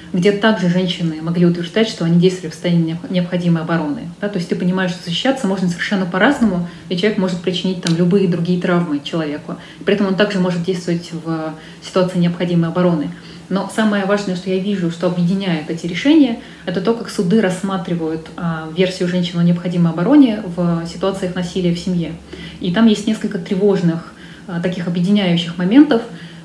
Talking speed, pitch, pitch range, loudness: 170 wpm, 180 Hz, 170-195 Hz, -17 LUFS